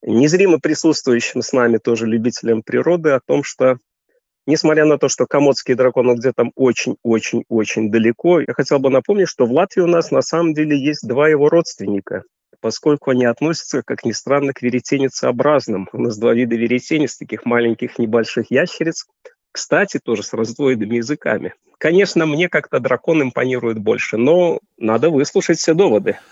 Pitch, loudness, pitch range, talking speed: 135 Hz, -16 LUFS, 120-160 Hz, 155 wpm